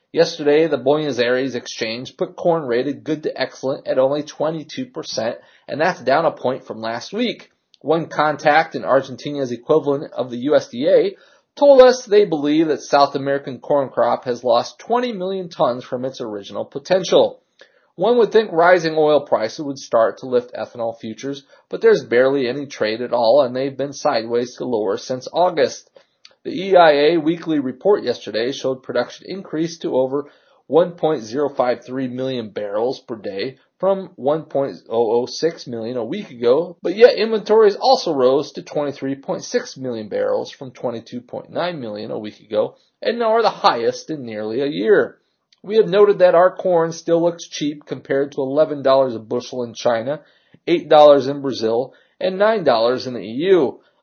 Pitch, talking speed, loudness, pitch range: 150 Hz, 160 wpm, -19 LUFS, 130-195 Hz